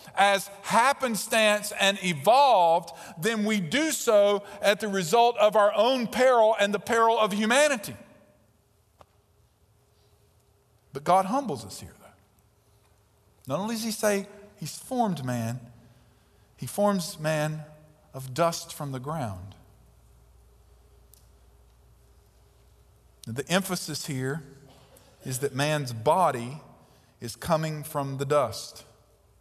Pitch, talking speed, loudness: 150 Hz, 110 wpm, -25 LUFS